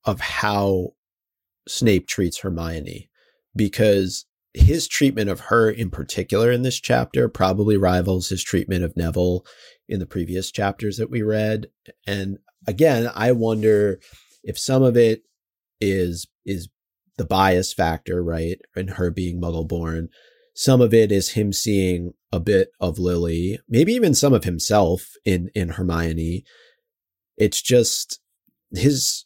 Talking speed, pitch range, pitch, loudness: 140 wpm, 90-115 Hz, 95 Hz, -21 LUFS